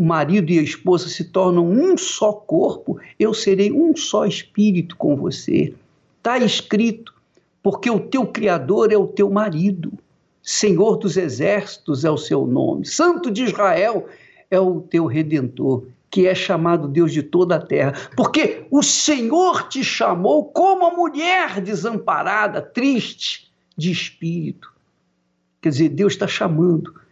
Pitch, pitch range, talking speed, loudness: 195 Hz, 170-225 Hz, 145 wpm, -18 LUFS